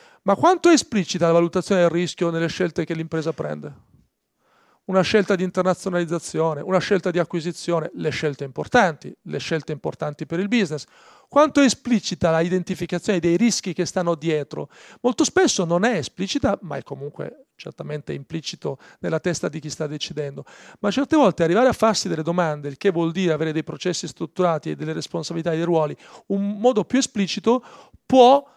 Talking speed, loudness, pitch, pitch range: 175 wpm, -22 LUFS, 175 Hz, 160-205 Hz